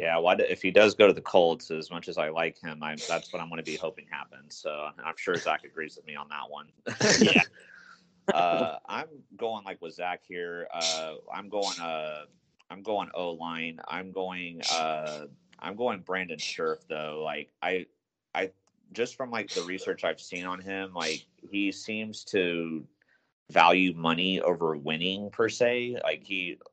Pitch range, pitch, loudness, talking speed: 80-95 Hz, 85 Hz, -29 LUFS, 185 wpm